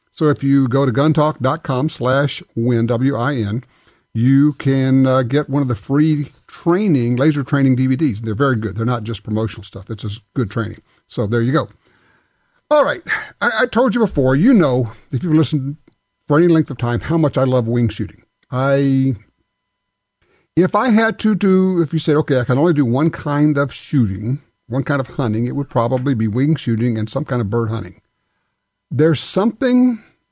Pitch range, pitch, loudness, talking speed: 120-150 Hz, 135 Hz, -17 LUFS, 190 wpm